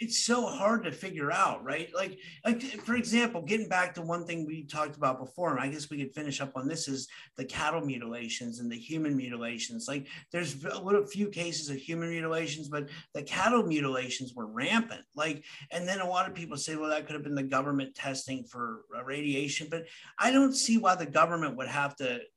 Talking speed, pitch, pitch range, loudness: 215 wpm, 155 Hz, 140-185 Hz, -32 LUFS